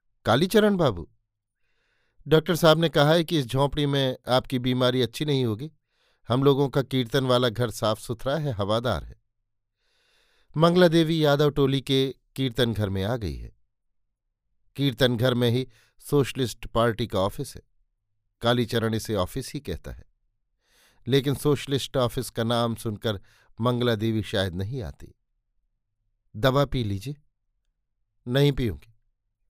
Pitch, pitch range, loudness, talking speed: 120 Hz, 110-140 Hz, -24 LUFS, 140 wpm